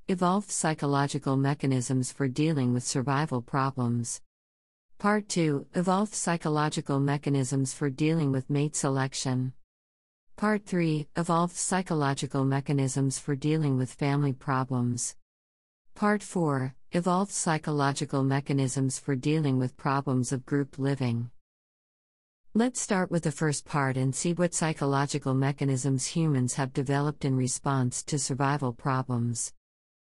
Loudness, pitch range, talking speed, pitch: -28 LUFS, 130-155 Hz, 120 wpm, 140 Hz